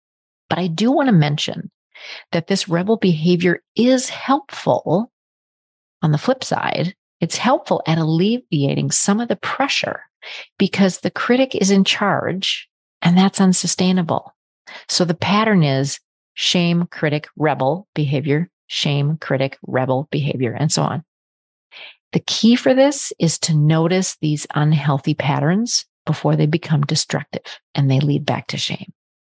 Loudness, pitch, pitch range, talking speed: -18 LUFS, 165 Hz, 150-195 Hz, 140 wpm